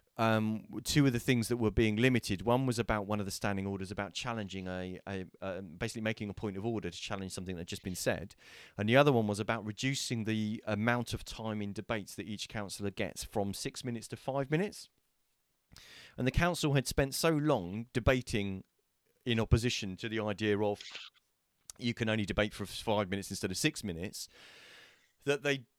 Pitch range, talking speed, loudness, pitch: 100-120 Hz, 200 wpm, -34 LUFS, 110 Hz